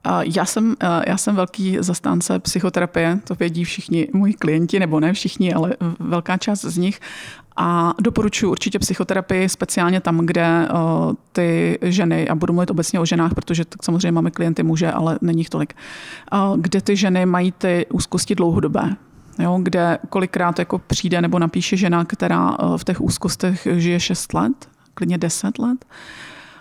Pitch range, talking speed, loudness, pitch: 170-195 Hz, 160 wpm, -19 LUFS, 180 Hz